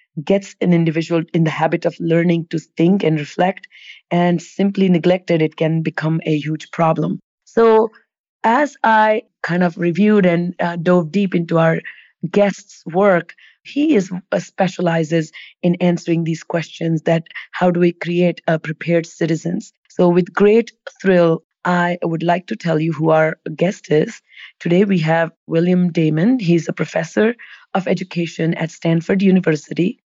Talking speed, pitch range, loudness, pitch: 155 wpm, 165-190 Hz, -17 LUFS, 175 Hz